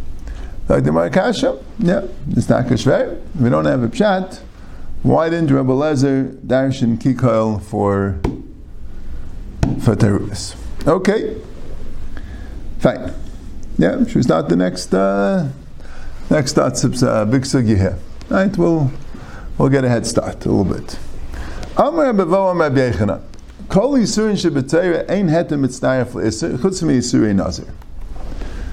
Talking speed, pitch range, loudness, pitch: 150 wpm, 90-140 Hz, -17 LUFS, 110 Hz